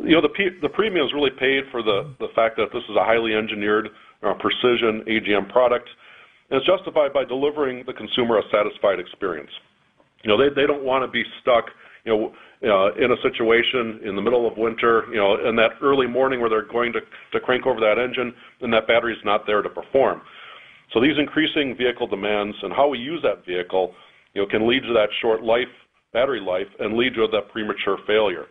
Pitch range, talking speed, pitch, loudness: 110-130 Hz, 215 wpm, 120 Hz, -21 LUFS